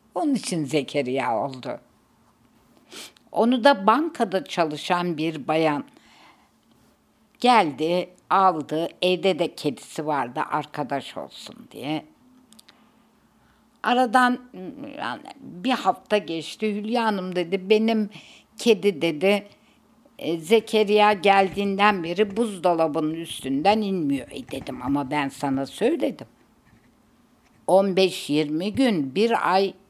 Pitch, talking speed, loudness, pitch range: 190 Hz, 90 wpm, -23 LUFS, 160-220 Hz